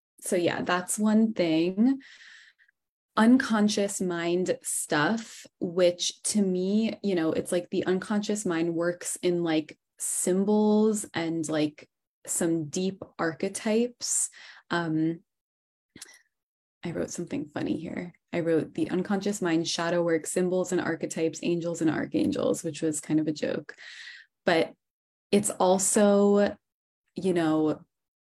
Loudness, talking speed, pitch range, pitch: -27 LUFS, 120 wpm, 170-210 Hz, 180 Hz